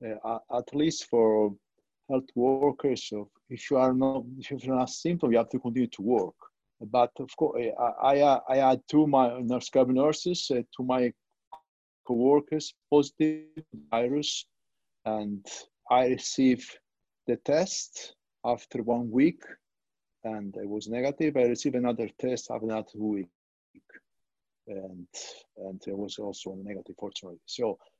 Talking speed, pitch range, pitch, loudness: 140 wpm, 110-135 Hz, 125 Hz, -28 LUFS